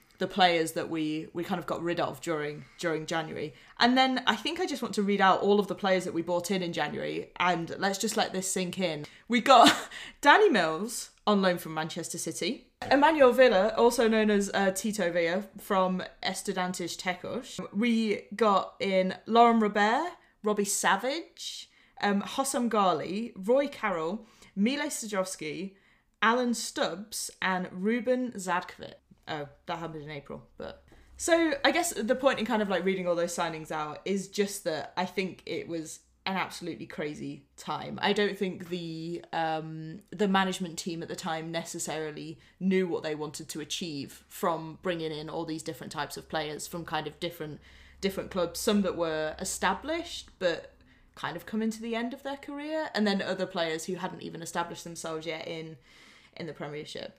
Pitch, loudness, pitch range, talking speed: 185 Hz, -29 LUFS, 165-215 Hz, 180 wpm